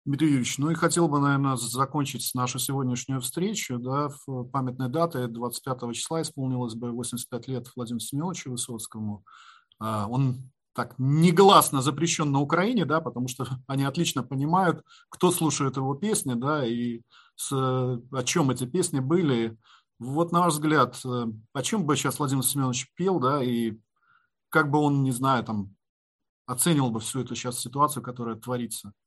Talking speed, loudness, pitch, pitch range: 155 wpm, -26 LUFS, 130 Hz, 120-150 Hz